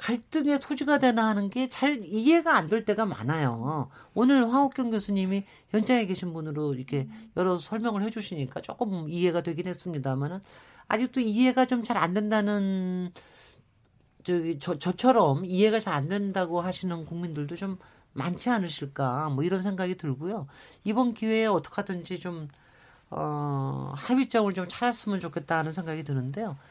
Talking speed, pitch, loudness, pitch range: 325 characters per minute, 185 Hz, -28 LUFS, 160-225 Hz